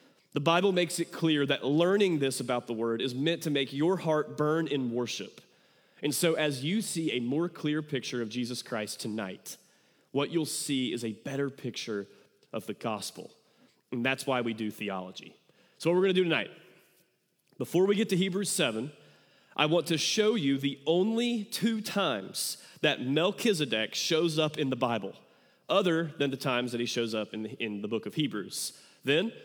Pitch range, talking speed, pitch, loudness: 120-170 Hz, 190 wpm, 145 Hz, -30 LUFS